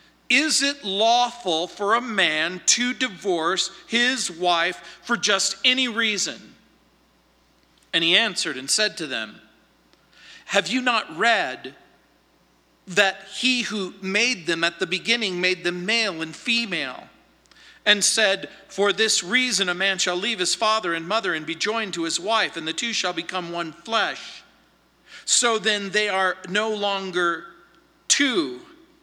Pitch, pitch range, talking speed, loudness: 200 Hz, 175-230 Hz, 145 wpm, -22 LUFS